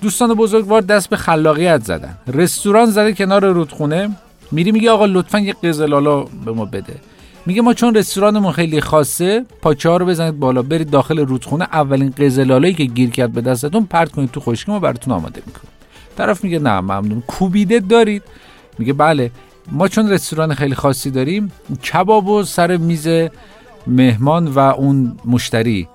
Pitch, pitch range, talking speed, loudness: 160 Hz, 135-205 Hz, 160 wpm, -15 LUFS